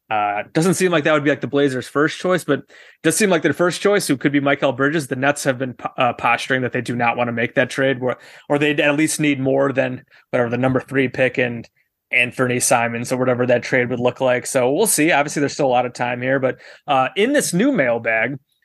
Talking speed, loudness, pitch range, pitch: 260 wpm, -18 LUFS, 125-150 Hz, 135 Hz